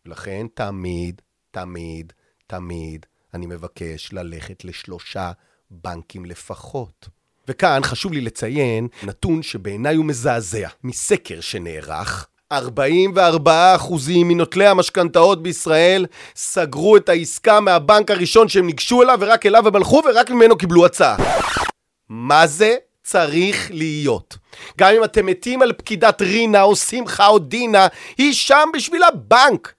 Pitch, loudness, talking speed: 175 Hz, -15 LUFS, 120 wpm